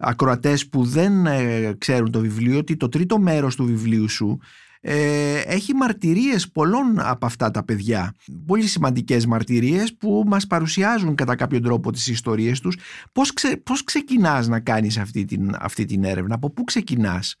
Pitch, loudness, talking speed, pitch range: 135 Hz, -21 LUFS, 165 wpm, 115-185 Hz